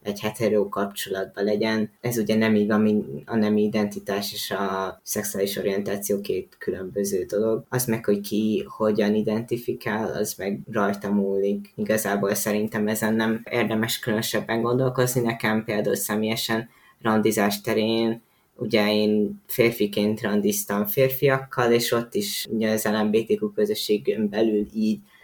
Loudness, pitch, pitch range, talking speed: -24 LUFS, 110 Hz, 105-115 Hz, 130 wpm